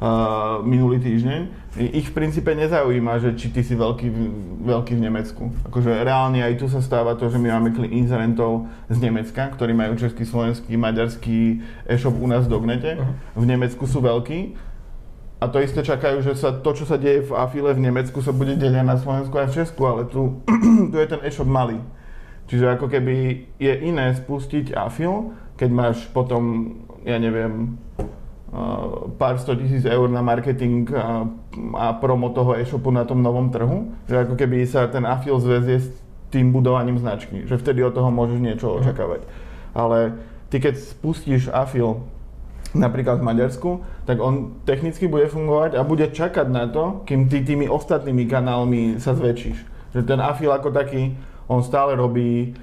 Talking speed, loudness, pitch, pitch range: 170 wpm, -21 LUFS, 125 Hz, 120-135 Hz